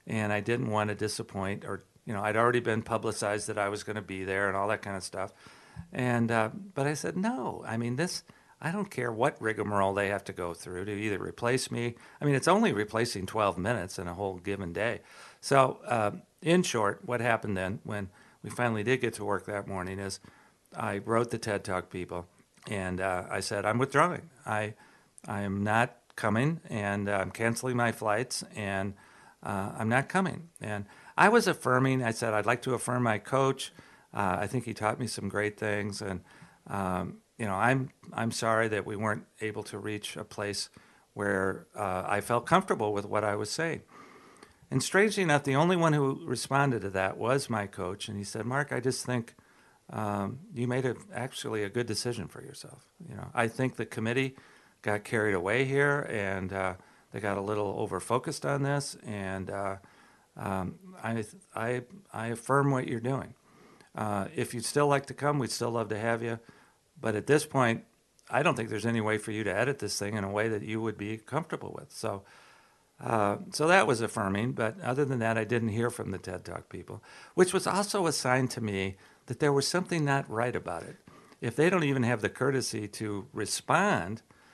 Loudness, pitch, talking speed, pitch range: -31 LUFS, 110 Hz, 205 wpm, 100-130 Hz